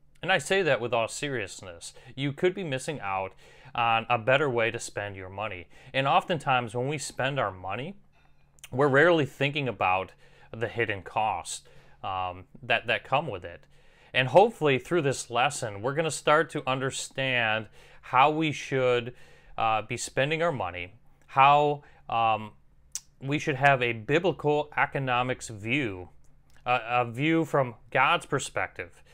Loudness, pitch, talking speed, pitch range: -27 LUFS, 130 Hz, 150 wpm, 115-150 Hz